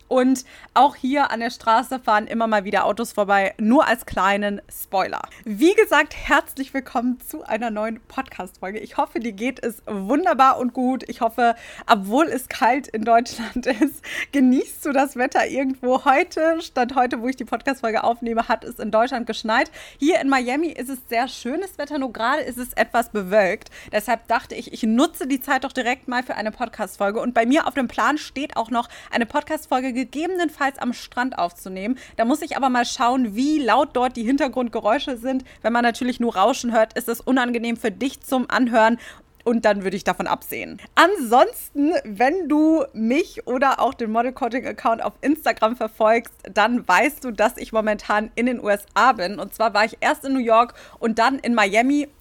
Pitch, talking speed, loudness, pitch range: 250 Hz, 190 wpm, -21 LUFS, 225-275 Hz